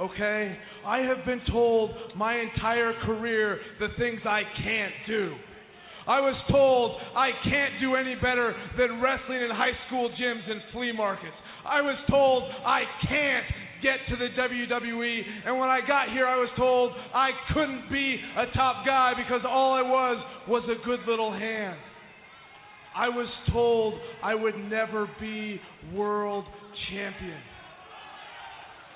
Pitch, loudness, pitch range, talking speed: 240 Hz, -27 LUFS, 215-255 Hz, 145 wpm